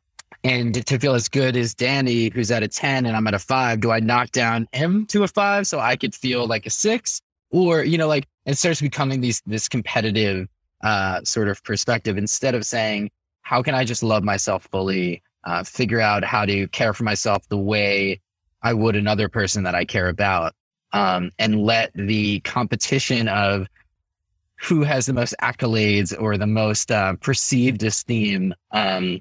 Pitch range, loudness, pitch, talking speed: 100-125 Hz, -21 LUFS, 110 Hz, 185 wpm